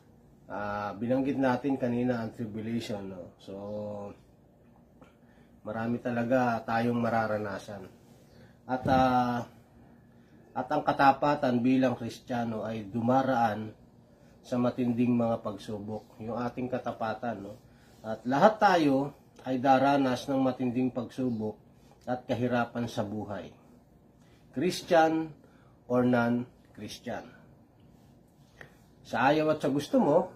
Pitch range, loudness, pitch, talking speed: 115-130 Hz, -29 LUFS, 120 Hz, 100 wpm